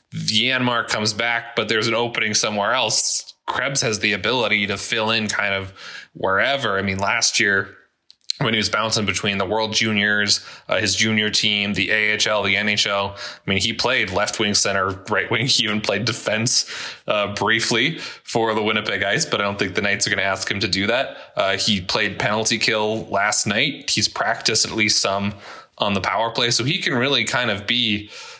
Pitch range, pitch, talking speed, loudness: 100-115 Hz, 105 Hz, 200 wpm, -19 LUFS